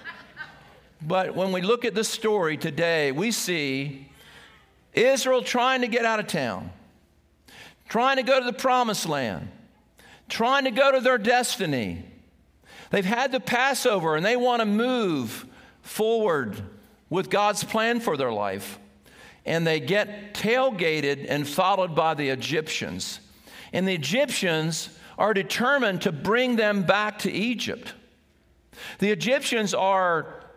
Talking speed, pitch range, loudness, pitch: 135 wpm, 165-245 Hz, -24 LUFS, 205 Hz